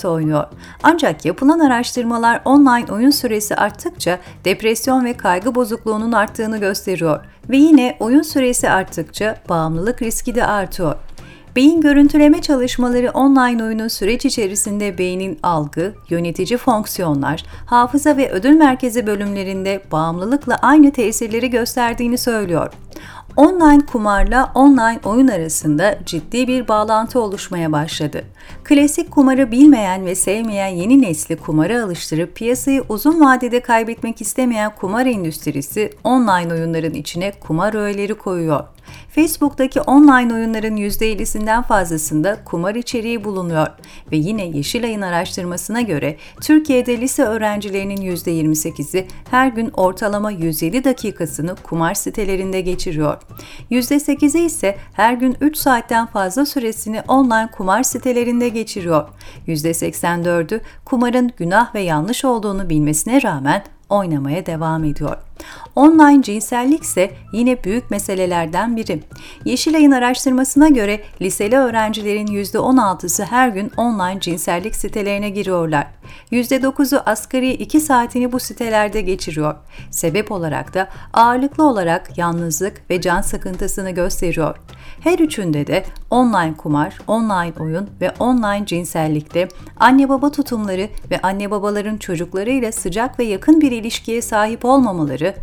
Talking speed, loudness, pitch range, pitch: 115 wpm, -16 LUFS, 180-250 Hz, 215 Hz